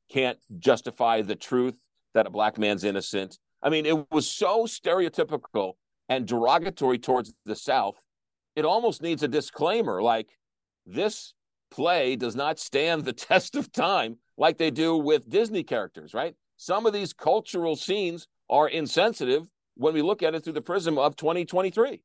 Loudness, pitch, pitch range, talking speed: -26 LUFS, 155 Hz, 125-175 Hz, 160 wpm